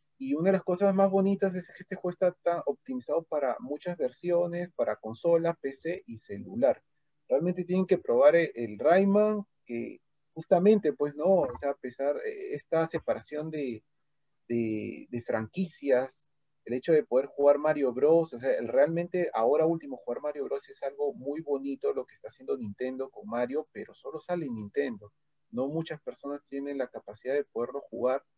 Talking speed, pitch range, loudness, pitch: 175 wpm, 135-180 Hz, -29 LUFS, 150 Hz